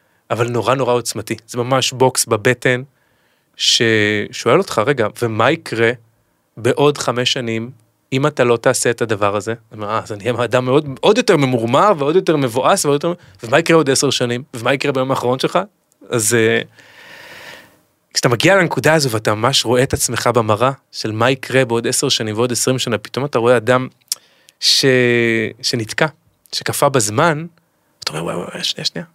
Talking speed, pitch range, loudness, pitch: 165 wpm, 115-140 Hz, -16 LUFS, 125 Hz